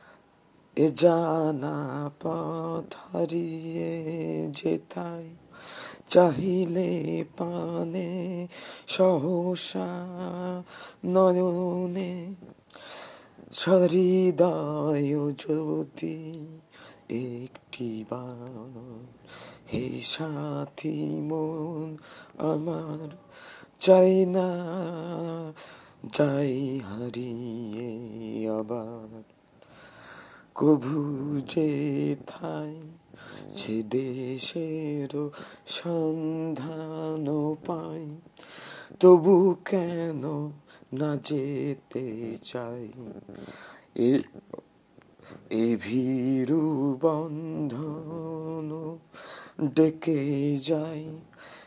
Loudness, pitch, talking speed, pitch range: -28 LUFS, 155 Hz, 45 wpm, 130-165 Hz